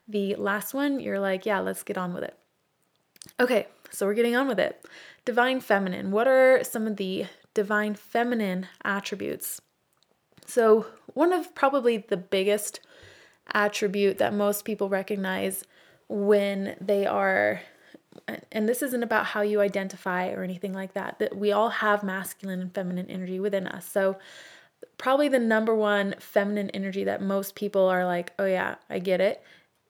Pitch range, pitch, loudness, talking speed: 195-220 Hz, 205 Hz, -26 LUFS, 160 wpm